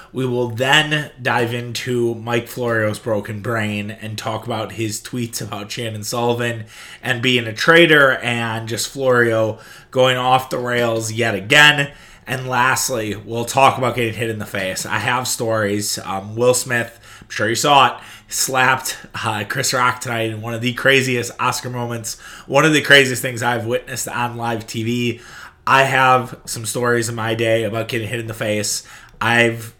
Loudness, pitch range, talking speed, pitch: -17 LUFS, 110-125 Hz, 175 wpm, 120 Hz